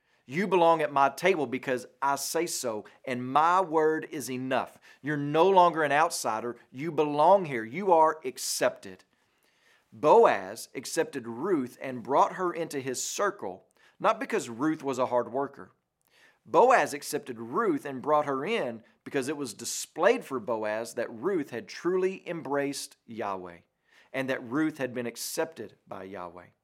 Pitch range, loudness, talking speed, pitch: 125-160 Hz, -28 LUFS, 155 wpm, 140 Hz